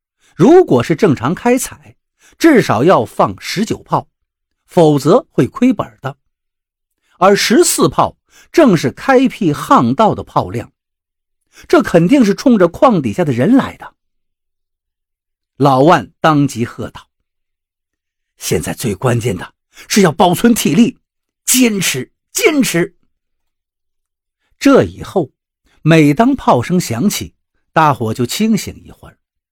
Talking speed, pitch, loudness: 175 characters per minute, 170 Hz, -12 LUFS